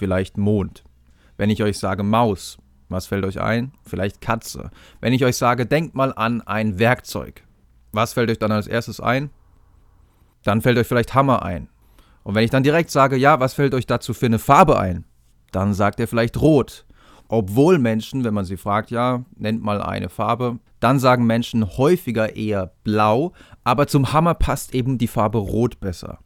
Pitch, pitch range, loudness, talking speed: 110 Hz, 95-125 Hz, -20 LUFS, 185 wpm